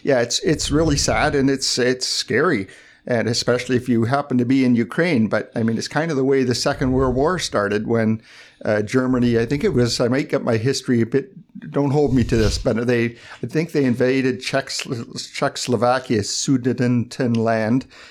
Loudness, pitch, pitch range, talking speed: -20 LUFS, 125 Hz, 115-135 Hz, 195 wpm